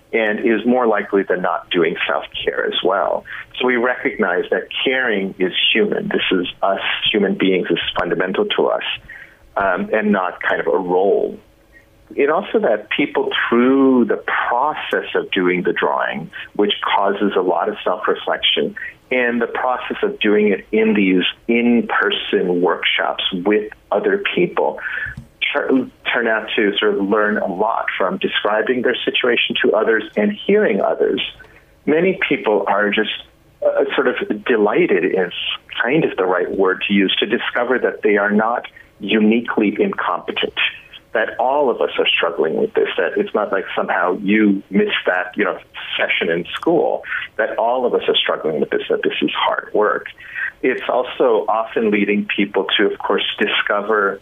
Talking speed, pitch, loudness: 165 wpm, 125 Hz, -18 LUFS